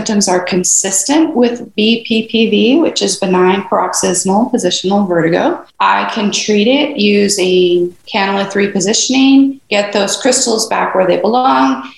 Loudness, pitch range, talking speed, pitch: -12 LUFS, 185-230 Hz, 130 wpm, 205 Hz